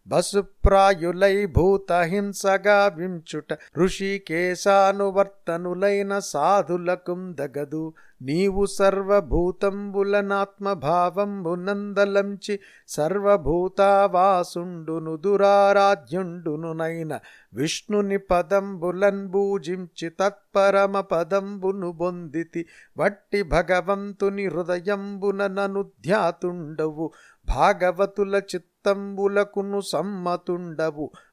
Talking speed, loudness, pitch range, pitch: 50 wpm, -23 LUFS, 175-200 Hz, 195 Hz